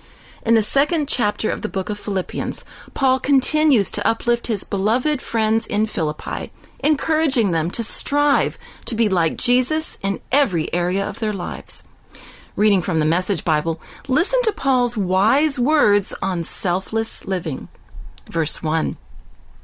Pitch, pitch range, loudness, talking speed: 220 Hz, 190-270 Hz, -19 LUFS, 145 wpm